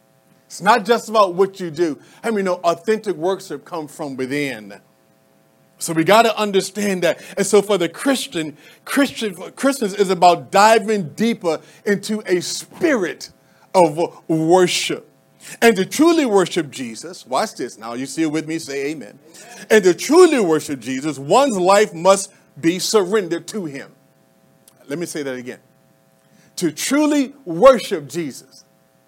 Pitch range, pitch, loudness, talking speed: 160-215 Hz, 185 Hz, -18 LUFS, 155 wpm